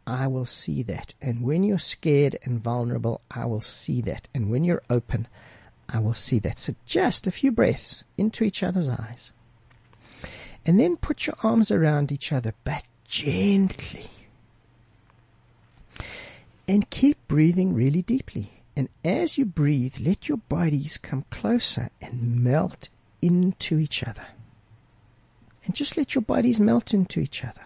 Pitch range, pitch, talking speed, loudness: 115-185 Hz, 130 Hz, 150 wpm, -24 LUFS